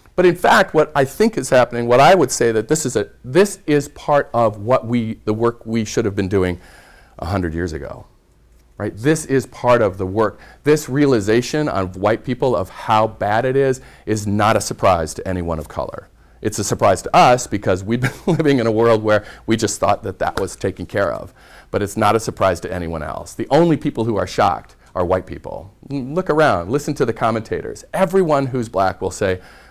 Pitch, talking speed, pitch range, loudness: 115 Hz, 220 wpm, 100-140 Hz, -18 LUFS